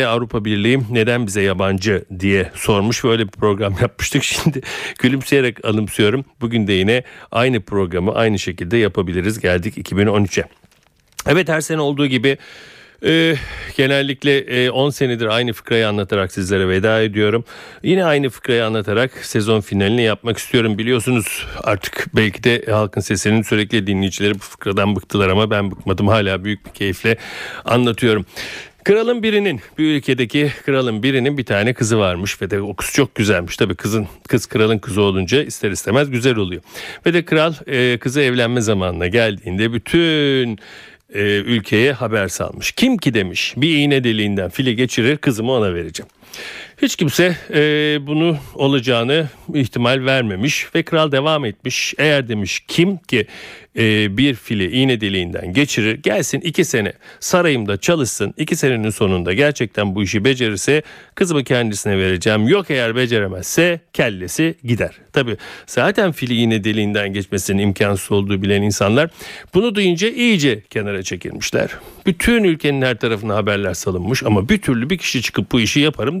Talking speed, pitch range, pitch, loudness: 150 wpm, 105-140 Hz, 115 Hz, -17 LUFS